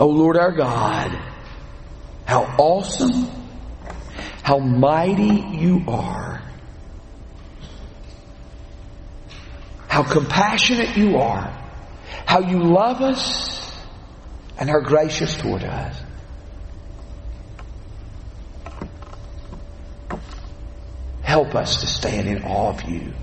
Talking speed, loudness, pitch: 80 wpm, -19 LUFS, 100 Hz